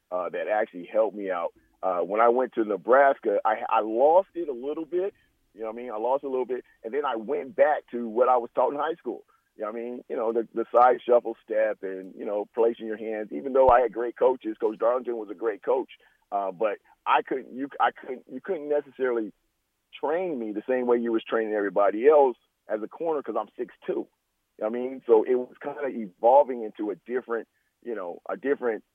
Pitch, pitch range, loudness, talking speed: 120 Hz, 110-135 Hz, -26 LUFS, 240 wpm